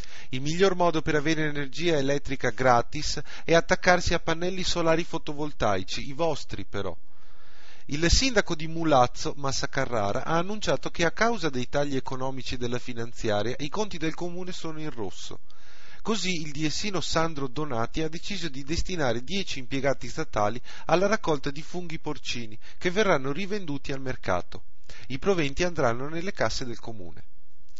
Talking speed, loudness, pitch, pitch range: 150 wpm, -28 LUFS, 150 Hz, 125-170 Hz